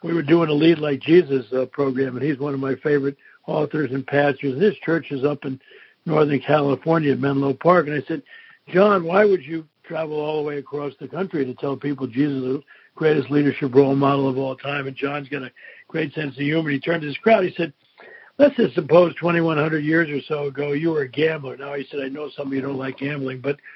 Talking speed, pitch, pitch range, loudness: 245 wpm, 145 Hz, 140-160 Hz, -21 LUFS